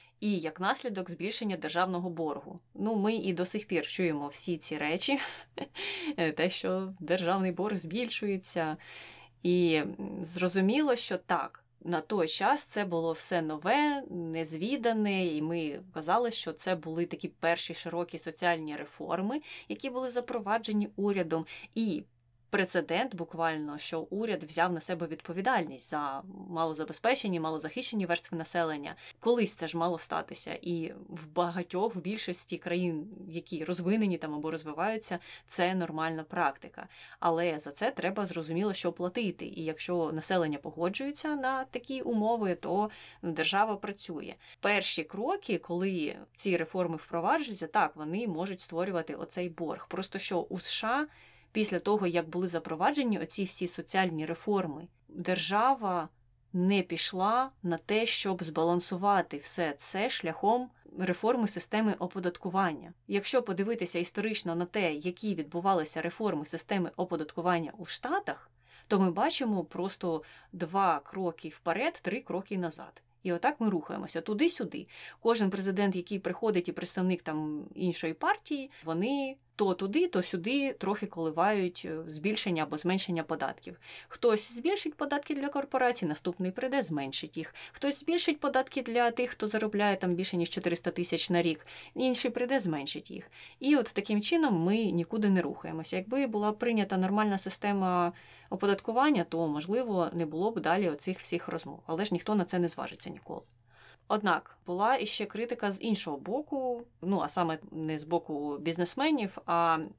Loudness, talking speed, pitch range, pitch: -32 LUFS, 140 wpm, 165-210 Hz, 180 Hz